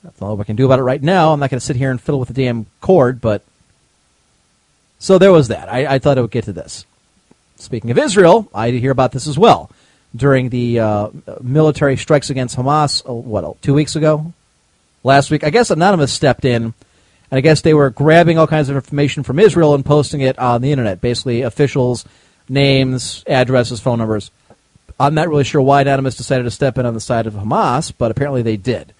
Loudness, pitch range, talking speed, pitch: -14 LUFS, 120-145 Hz, 220 wpm, 130 Hz